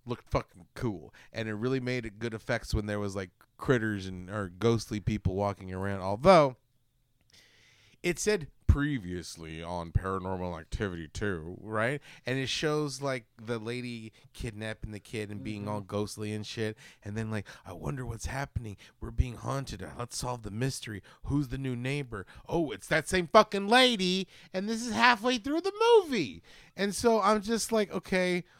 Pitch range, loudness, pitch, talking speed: 105-145 Hz, -30 LUFS, 120 Hz, 170 wpm